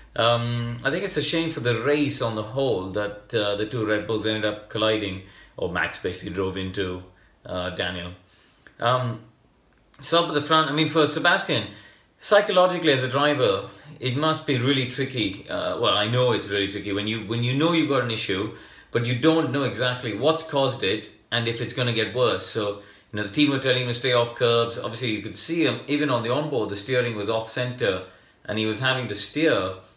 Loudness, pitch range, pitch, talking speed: -24 LUFS, 105-140 Hz, 120 Hz, 220 wpm